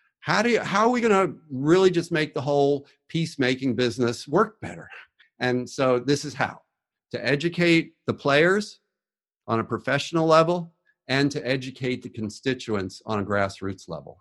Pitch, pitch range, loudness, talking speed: 140 Hz, 125-165 Hz, -24 LUFS, 165 wpm